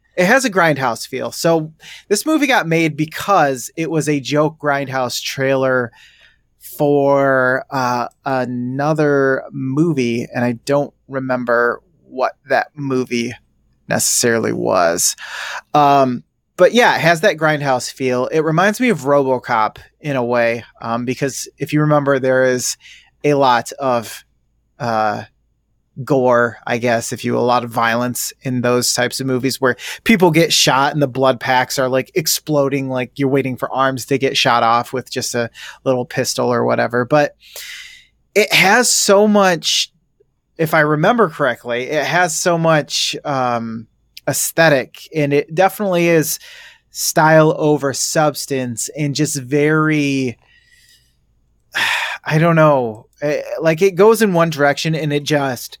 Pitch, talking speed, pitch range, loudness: 140 Hz, 145 wpm, 125-155 Hz, -16 LUFS